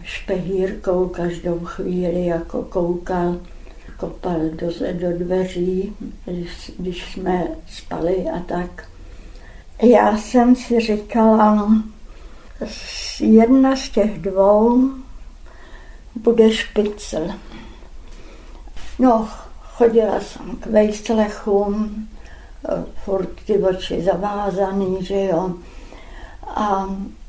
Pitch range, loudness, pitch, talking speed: 180-220 Hz, -19 LUFS, 195 Hz, 80 wpm